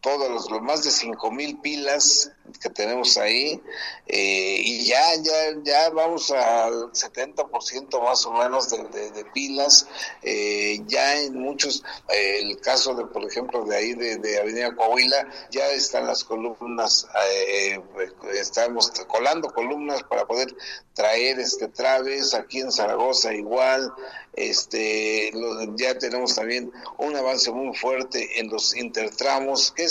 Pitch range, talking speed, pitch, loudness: 115-145 Hz, 150 wpm, 130 Hz, -22 LUFS